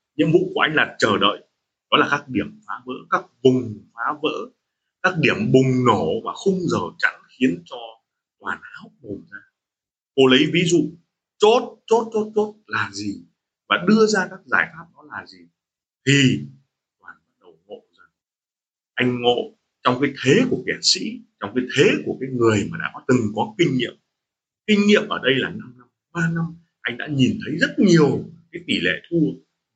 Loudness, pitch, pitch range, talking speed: -20 LUFS, 150 Hz, 125-190 Hz, 190 wpm